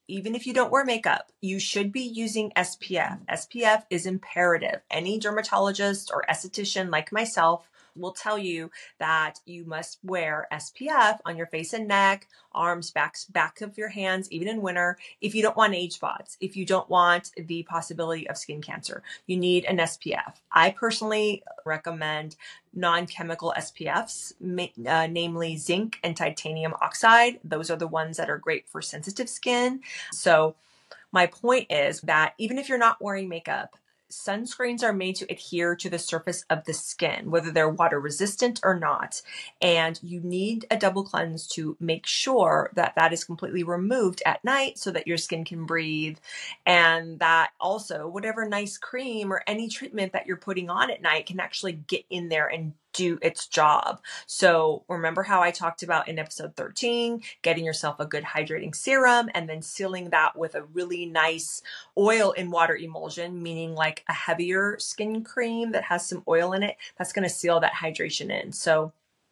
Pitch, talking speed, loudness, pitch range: 180 Hz, 175 wpm, -26 LUFS, 165-205 Hz